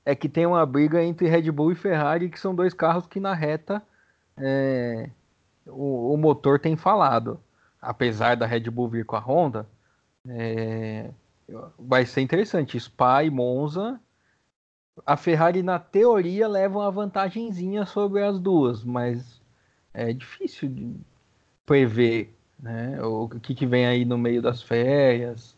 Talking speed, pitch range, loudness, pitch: 150 wpm, 120-175 Hz, -24 LUFS, 140 Hz